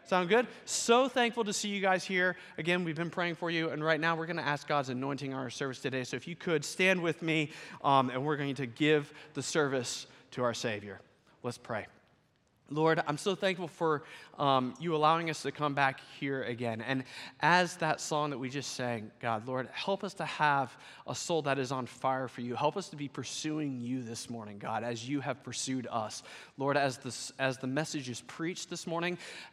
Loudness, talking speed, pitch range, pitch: -33 LUFS, 215 wpm, 130-165 Hz, 145 Hz